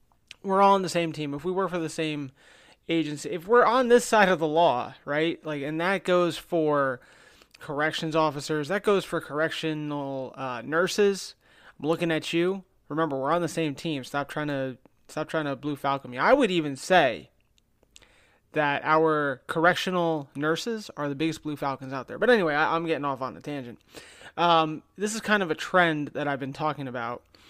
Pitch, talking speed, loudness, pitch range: 155 Hz, 195 wpm, -26 LUFS, 145-175 Hz